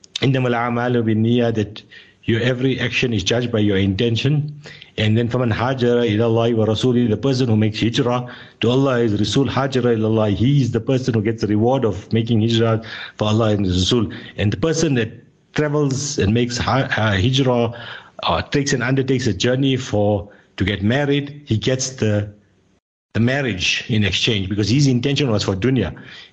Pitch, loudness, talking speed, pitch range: 120 Hz, -19 LUFS, 175 wpm, 110-130 Hz